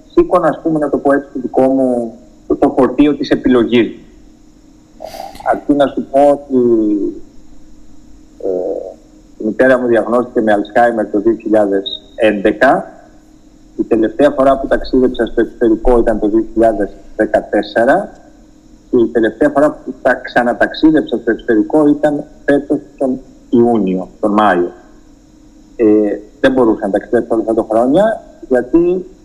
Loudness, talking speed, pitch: -13 LUFS, 130 wpm, 135 Hz